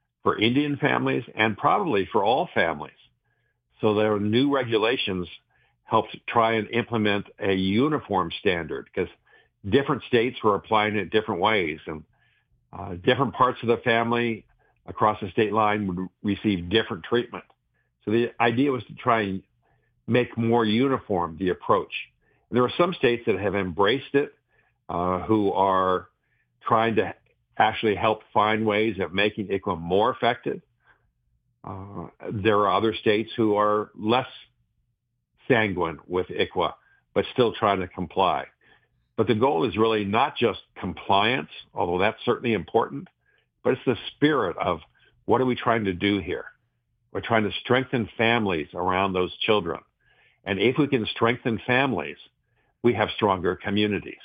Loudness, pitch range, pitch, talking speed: -24 LUFS, 100-120 Hz, 110 Hz, 150 wpm